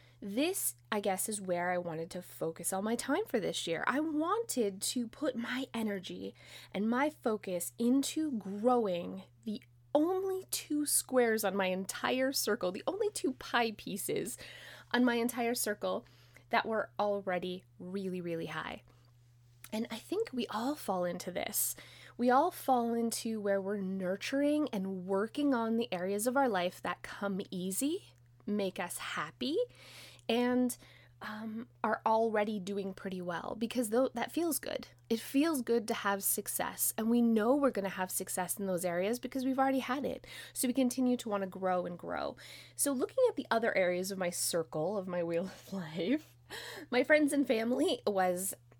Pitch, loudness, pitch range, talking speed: 220 Hz, -34 LUFS, 185-255 Hz, 170 wpm